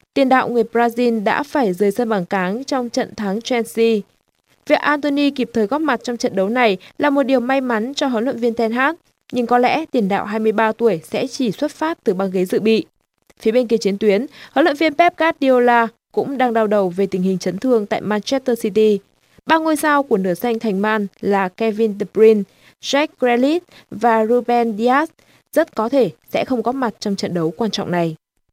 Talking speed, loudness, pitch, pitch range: 215 wpm, -18 LUFS, 235 Hz, 210-265 Hz